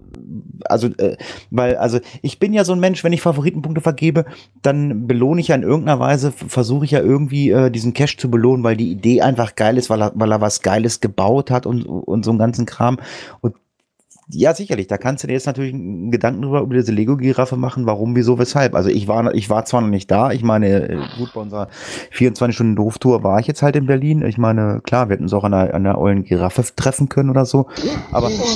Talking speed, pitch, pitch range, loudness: 225 wpm, 125 Hz, 110-140 Hz, -17 LUFS